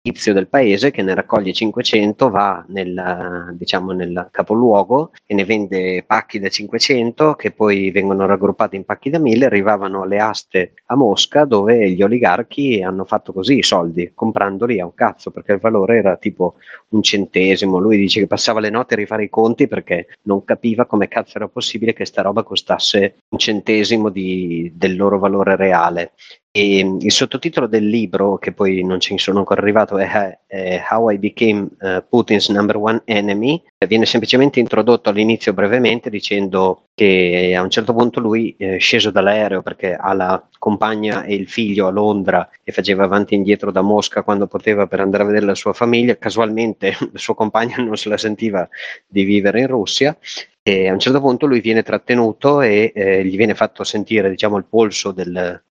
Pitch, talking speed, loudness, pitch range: 105 Hz, 180 wpm, -16 LUFS, 95-110 Hz